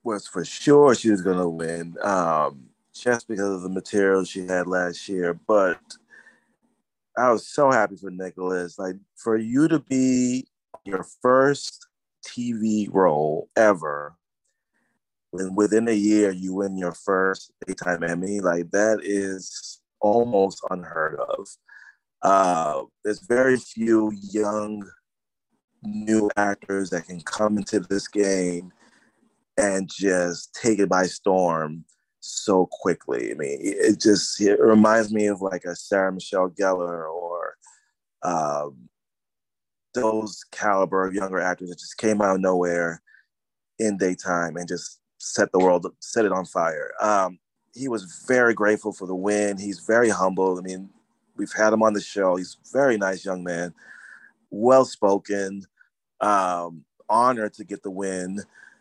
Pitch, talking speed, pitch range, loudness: 95 Hz, 145 wpm, 90-105 Hz, -23 LUFS